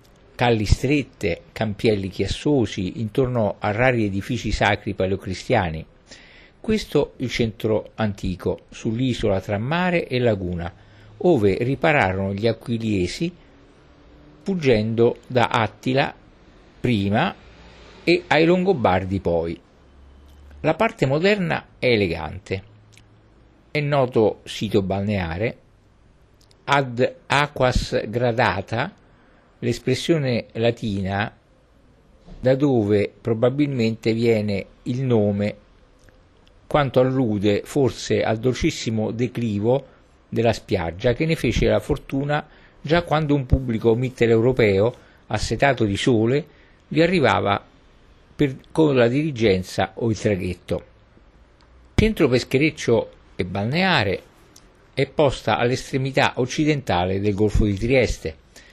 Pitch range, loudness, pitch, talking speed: 100-135 Hz, -21 LUFS, 115 Hz, 95 wpm